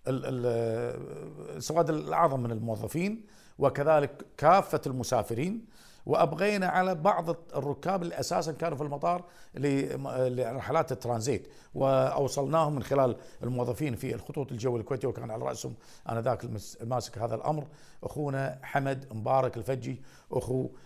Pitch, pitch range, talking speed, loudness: 135 Hz, 125-160 Hz, 110 wpm, -30 LUFS